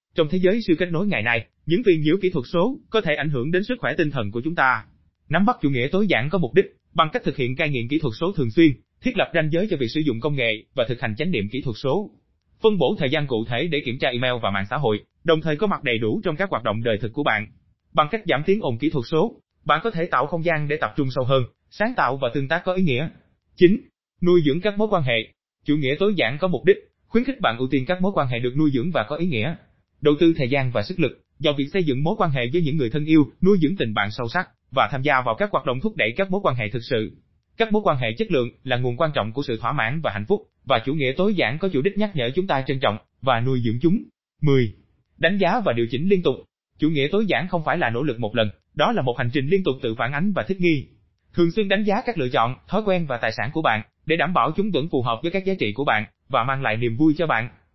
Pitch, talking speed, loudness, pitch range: 150 Hz, 300 wpm, -22 LUFS, 125-180 Hz